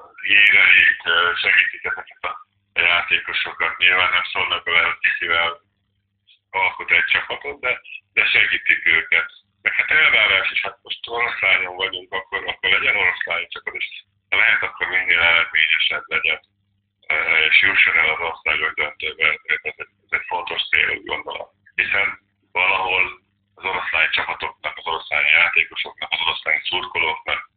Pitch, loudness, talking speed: 100 Hz, -17 LUFS, 130 wpm